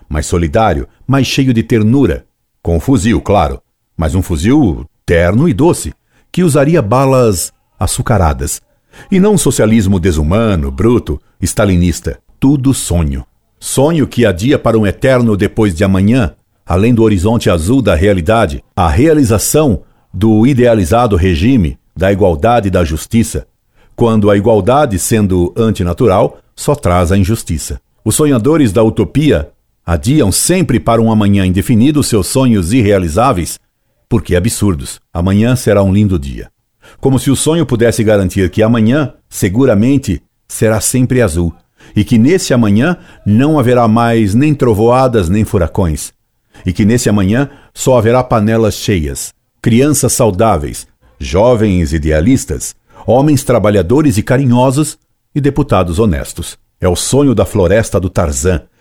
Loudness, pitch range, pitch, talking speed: -11 LUFS, 95-125 Hz, 110 Hz, 135 wpm